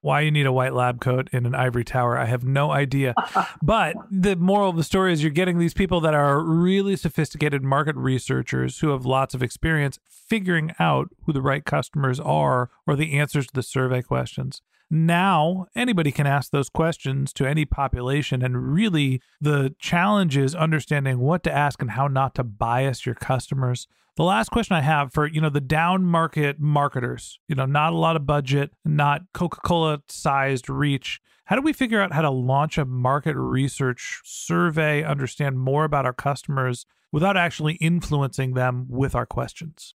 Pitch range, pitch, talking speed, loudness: 130-165 Hz, 145 Hz, 185 wpm, -22 LUFS